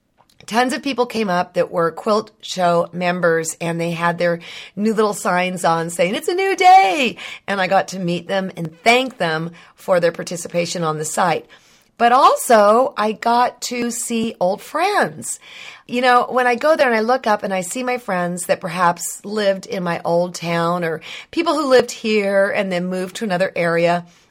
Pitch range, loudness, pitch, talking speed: 175-245 Hz, -18 LUFS, 195 Hz, 195 wpm